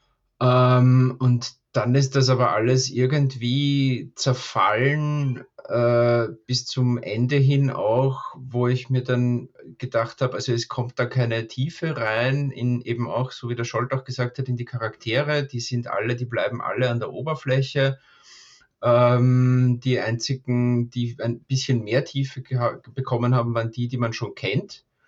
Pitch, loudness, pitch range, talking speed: 125 Hz, -23 LUFS, 120-130 Hz, 150 wpm